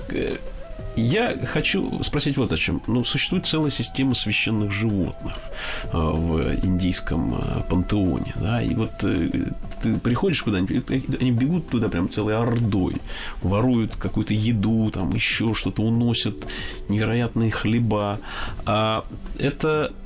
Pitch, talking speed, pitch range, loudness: 110 Hz, 115 wpm, 95-120 Hz, -23 LUFS